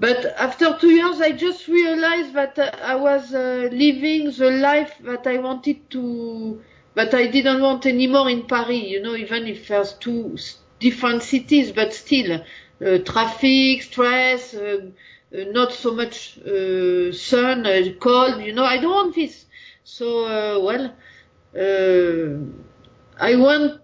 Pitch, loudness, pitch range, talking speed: 250 Hz, -19 LUFS, 220-275 Hz, 150 wpm